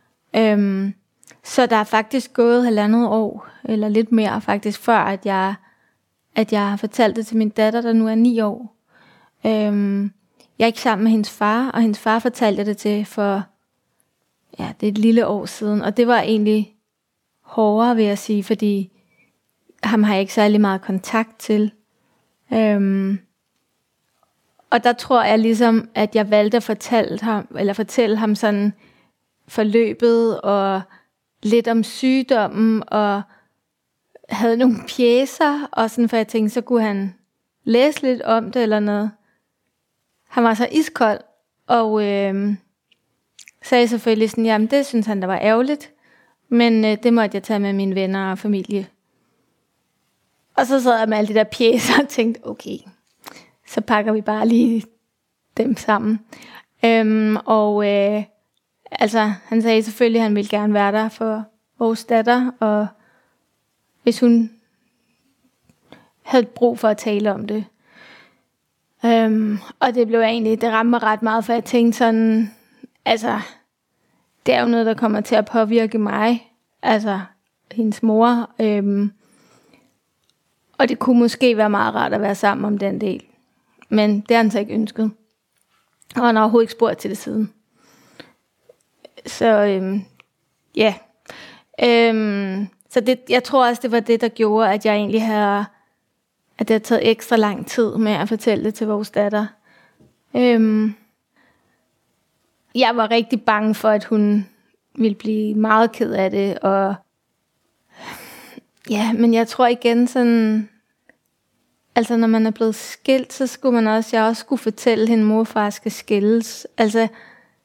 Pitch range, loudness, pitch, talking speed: 210-235 Hz, -18 LUFS, 220 Hz, 160 wpm